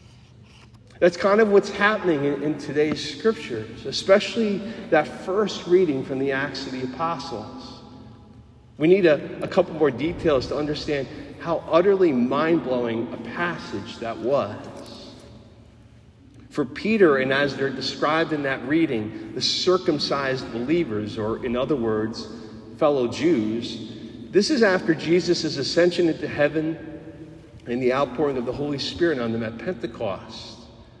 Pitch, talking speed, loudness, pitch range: 145 Hz, 140 wpm, -23 LUFS, 120-170 Hz